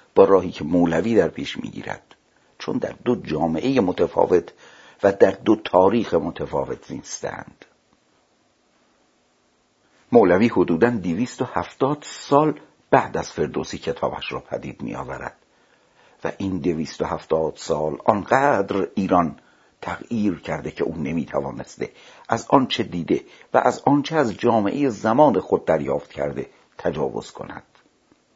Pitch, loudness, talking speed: 140 Hz, -22 LUFS, 125 wpm